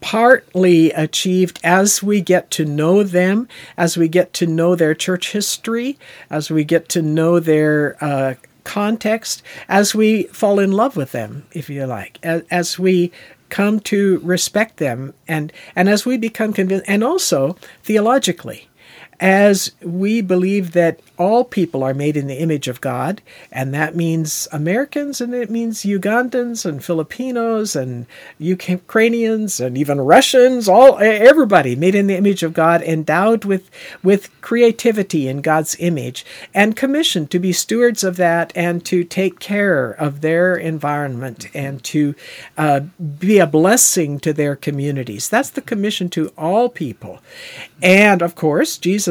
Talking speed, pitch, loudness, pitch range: 155 wpm, 180 Hz, -16 LUFS, 155-210 Hz